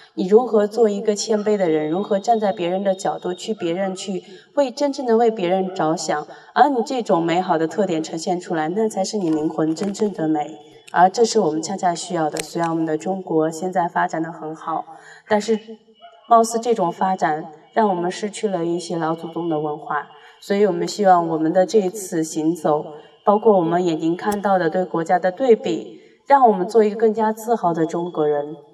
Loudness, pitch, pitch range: -20 LUFS, 185 Hz, 160-215 Hz